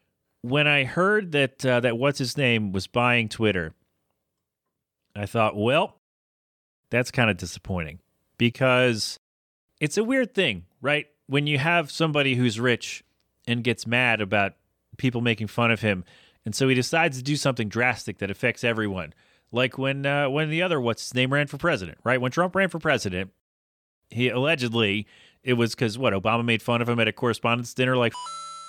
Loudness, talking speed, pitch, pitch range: -24 LUFS, 180 wpm, 120 Hz, 110-140 Hz